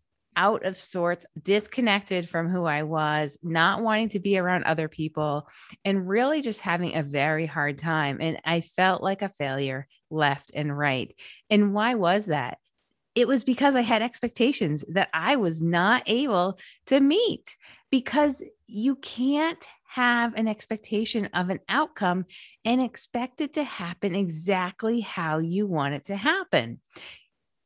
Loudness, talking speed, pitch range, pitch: -25 LUFS, 150 wpm, 160-235 Hz, 195 Hz